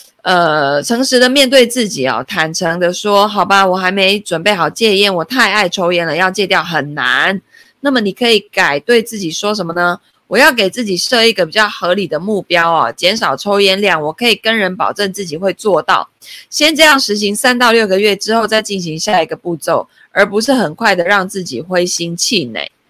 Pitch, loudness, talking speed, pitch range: 200 Hz, -12 LUFS, 300 characters per minute, 175-220 Hz